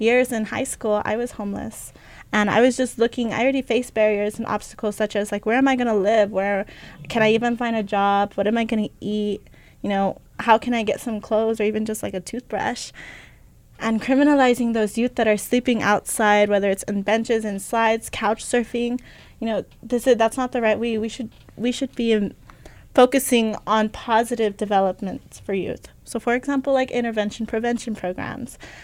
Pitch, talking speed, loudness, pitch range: 225 Hz, 205 wpm, -22 LUFS, 210-240 Hz